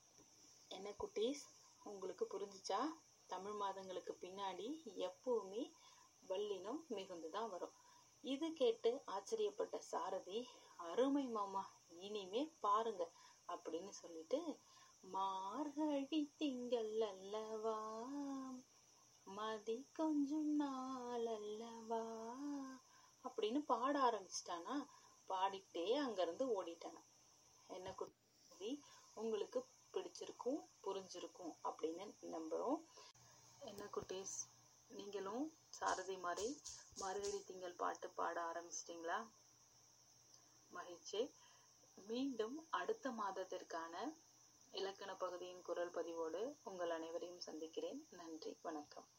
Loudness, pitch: -46 LUFS, 250 Hz